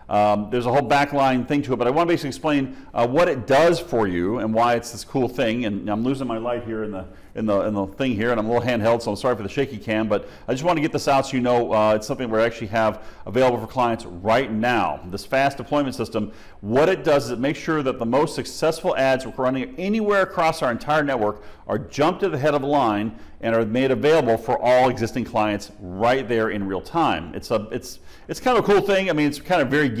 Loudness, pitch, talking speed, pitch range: -22 LUFS, 125 Hz, 270 wpm, 110-140 Hz